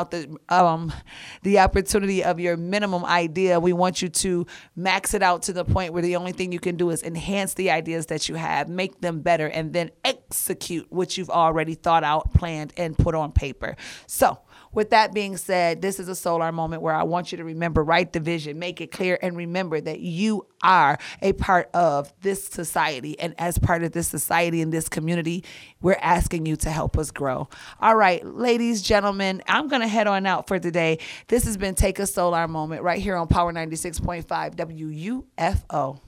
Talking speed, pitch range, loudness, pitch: 210 wpm, 165-190 Hz, -23 LUFS, 175 Hz